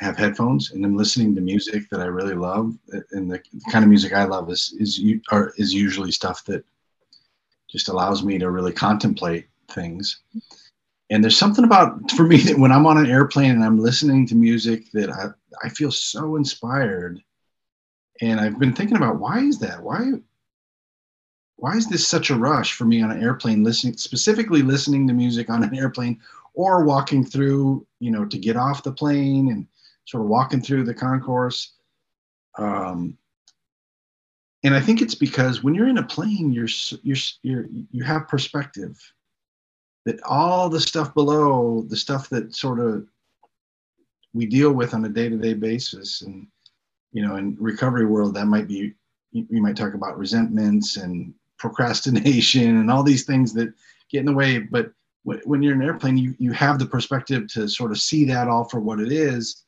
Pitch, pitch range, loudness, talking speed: 125 Hz, 110-145 Hz, -20 LUFS, 180 wpm